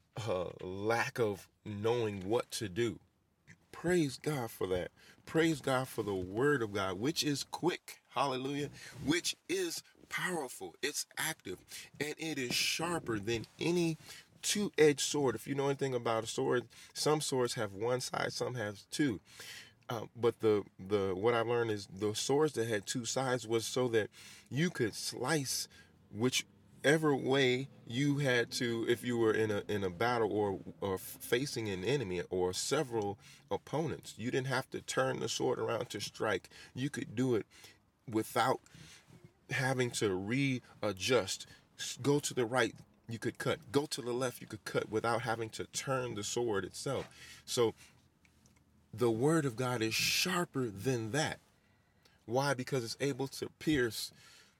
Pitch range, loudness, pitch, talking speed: 110-140 Hz, -35 LUFS, 125 Hz, 160 wpm